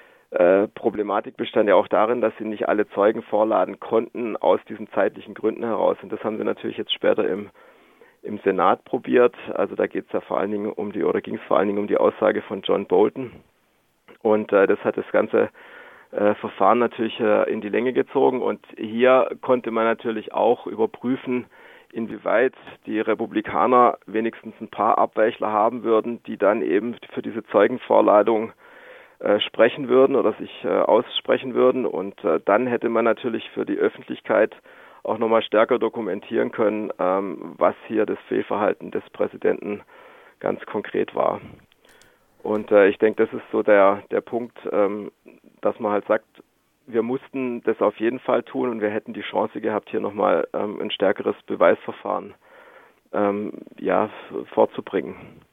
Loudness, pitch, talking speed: -22 LUFS, 120 Hz, 165 wpm